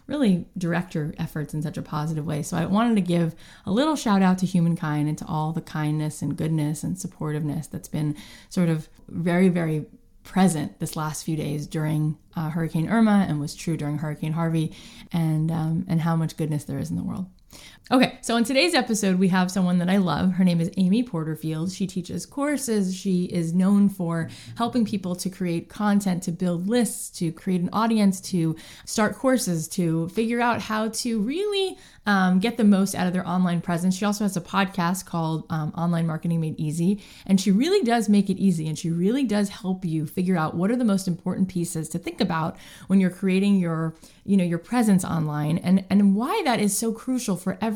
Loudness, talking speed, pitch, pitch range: -24 LUFS, 210 wpm, 180 Hz, 160-205 Hz